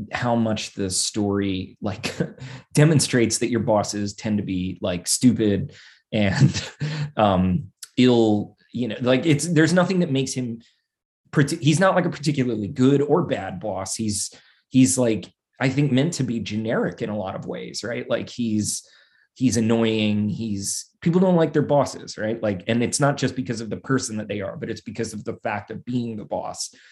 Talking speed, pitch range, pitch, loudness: 185 wpm, 105-135 Hz, 115 Hz, -22 LUFS